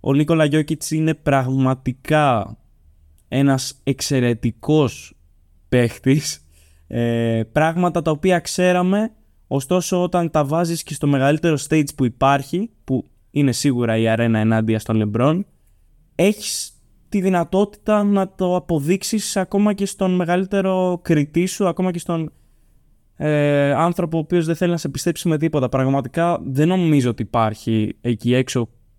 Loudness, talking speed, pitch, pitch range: -19 LUFS, 130 wpm, 150 Hz, 120-175 Hz